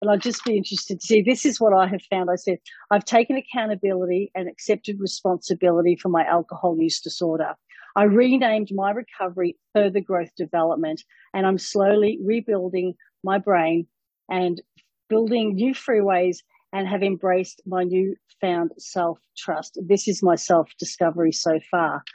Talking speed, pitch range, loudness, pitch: 155 wpm, 175-210 Hz, -22 LUFS, 190 Hz